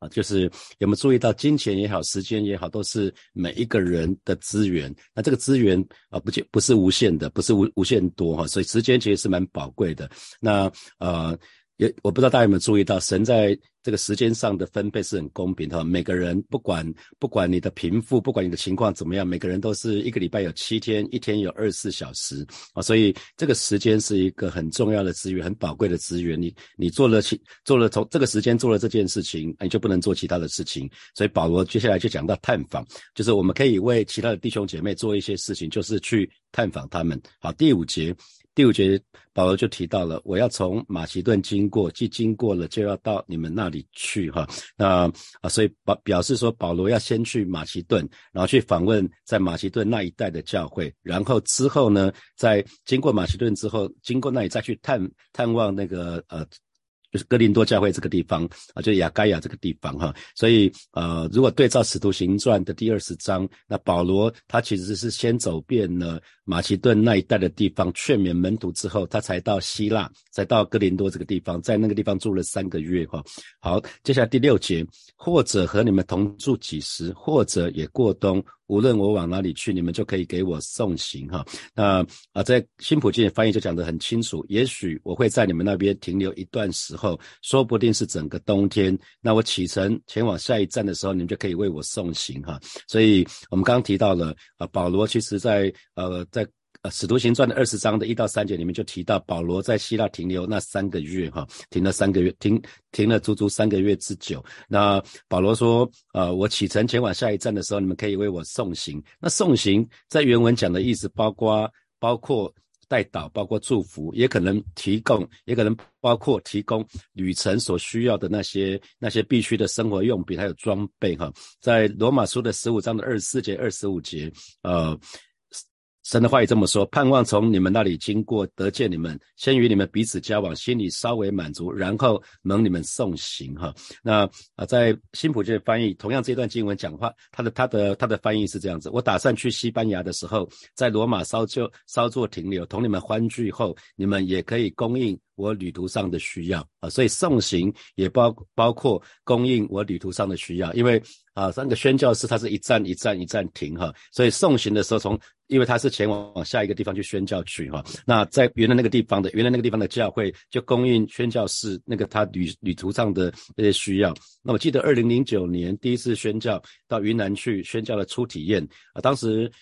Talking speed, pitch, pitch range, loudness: 315 characters per minute, 100 Hz, 90-115 Hz, -23 LUFS